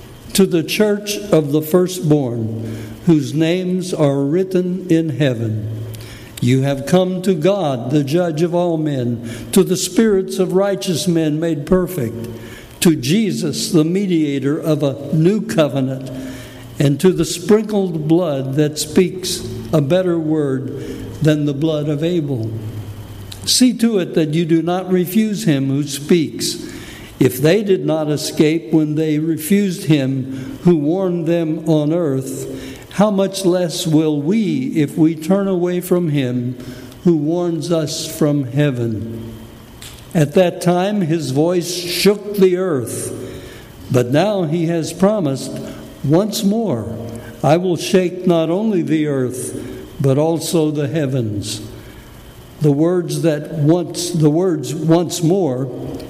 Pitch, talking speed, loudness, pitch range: 155 Hz, 135 wpm, -17 LUFS, 135-180 Hz